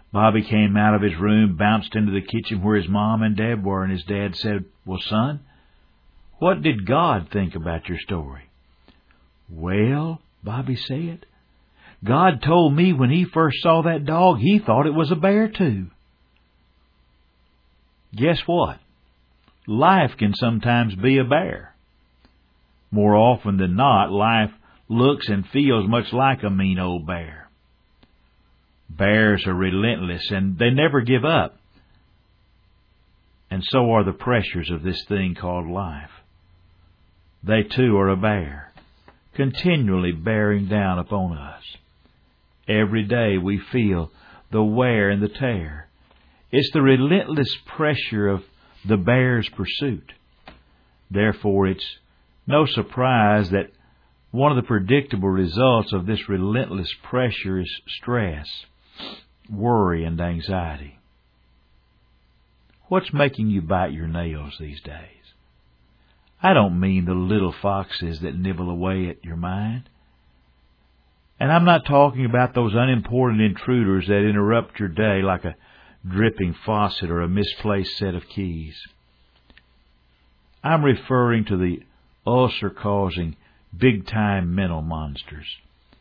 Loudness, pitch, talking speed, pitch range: -21 LUFS, 100 Hz, 130 wpm, 80-115 Hz